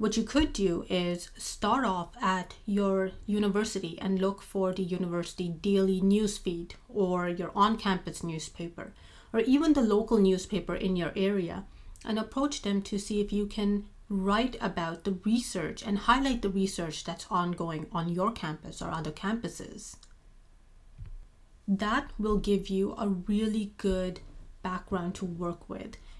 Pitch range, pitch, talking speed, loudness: 180-210 Hz, 195 Hz, 150 wpm, -30 LUFS